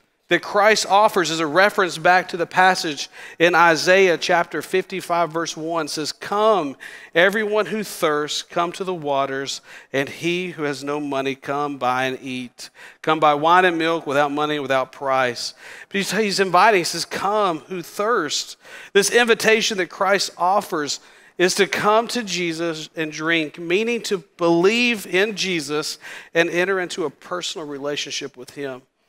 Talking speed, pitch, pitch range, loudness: 160 wpm, 170 Hz, 150-195 Hz, -20 LUFS